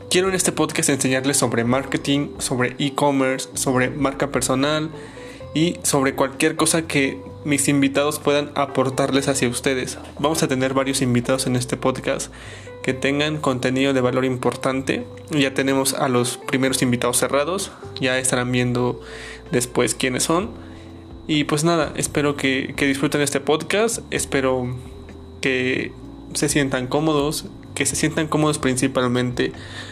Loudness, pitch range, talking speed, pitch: -21 LUFS, 125-145 Hz, 140 wpm, 135 Hz